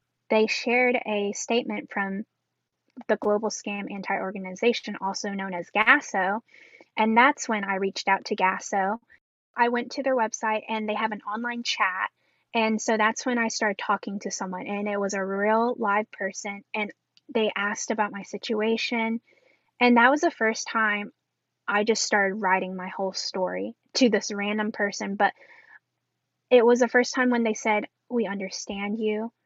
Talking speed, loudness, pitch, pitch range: 170 wpm, -25 LUFS, 215 Hz, 200-235 Hz